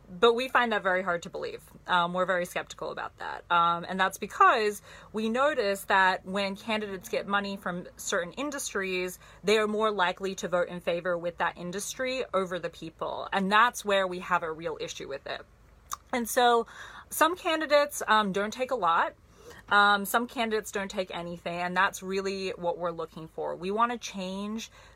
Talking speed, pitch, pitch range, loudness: 190 wpm, 195 Hz, 180-225 Hz, -28 LUFS